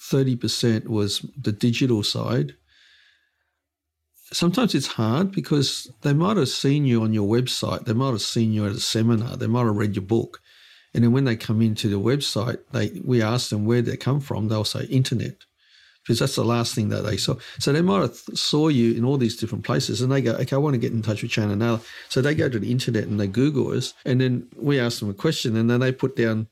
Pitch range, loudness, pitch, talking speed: 110-135 Hz, -23 LUFS, 120 Hz, 240 wpm